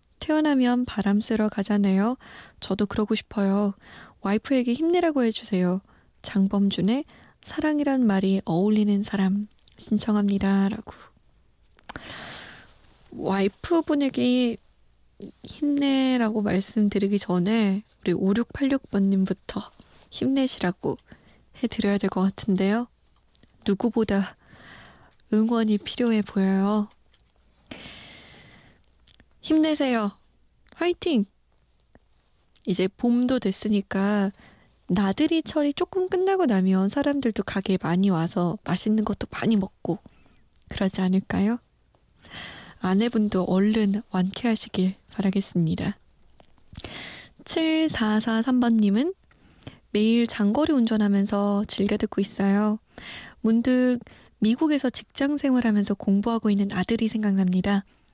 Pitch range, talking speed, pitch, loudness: 195-245 Hz, 230 characters per minute, 210 Hz, -24 LUFS